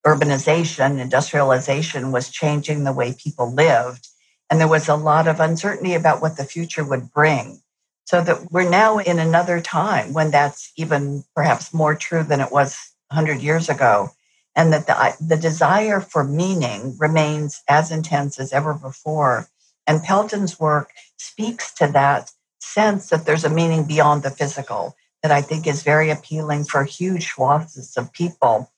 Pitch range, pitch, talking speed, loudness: 140-165 Hz, 155 Hz, 165 wpm, -19 LUFS